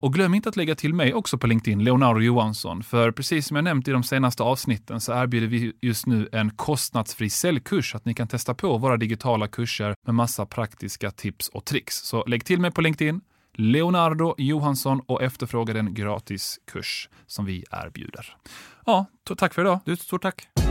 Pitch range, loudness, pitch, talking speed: 115-155 Hz, -24 LUFS, 125 Hz, 200 wpm